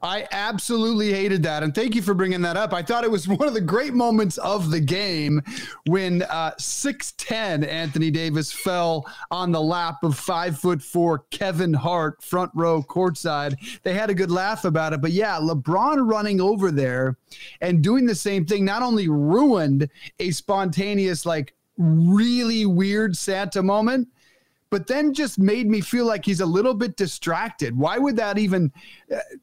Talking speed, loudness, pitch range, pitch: 170 wpm, -22 LUFS, 160-215 Hz, 185 Hz